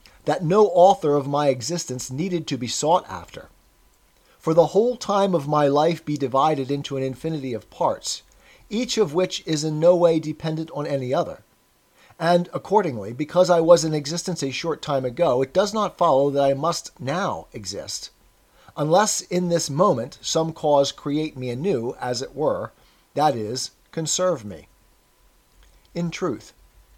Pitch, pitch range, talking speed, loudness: 160 Hz, 140-175 Hz, 165 wpm, -22 LUFS